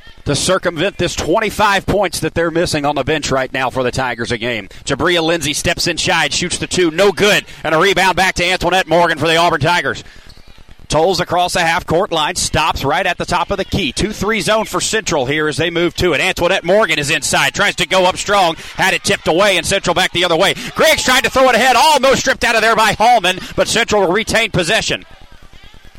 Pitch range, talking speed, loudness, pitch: 155-195 Hz, 230 wpm, -14 LUFS, 175 Hz